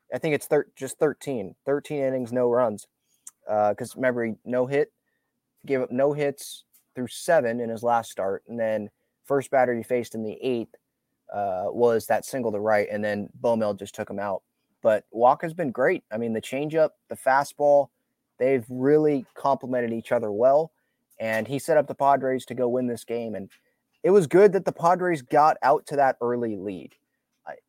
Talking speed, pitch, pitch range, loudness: 190 wpm, 125 Hz, 115-140 Hz, -25 LUFS